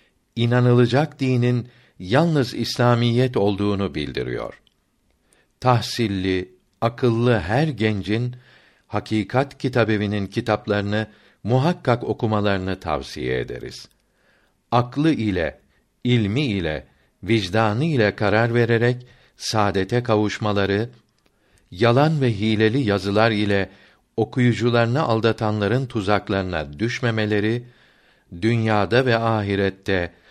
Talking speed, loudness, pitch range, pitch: 75 wpm, -21 LUFS, 100-120 Hz, 110 Hz